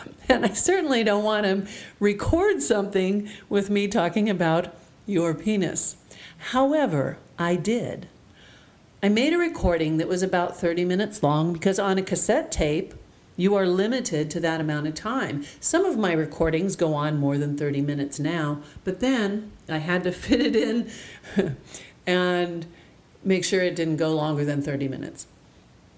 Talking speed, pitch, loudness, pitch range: 160 wpm, 180 Hz, -24 LUFS, 160-210 Hz